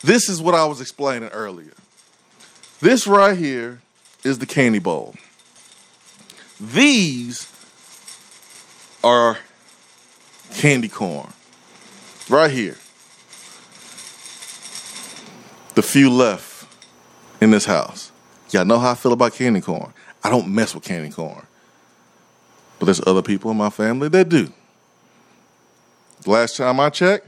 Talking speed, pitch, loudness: 115 wpm, 115 Hz, -18 LUFS